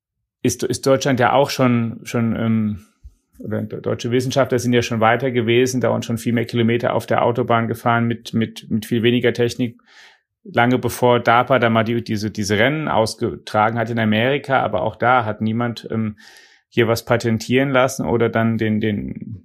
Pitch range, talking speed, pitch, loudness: 110-125 Hz, 180 wpm, 115 Hz, -19 LUFS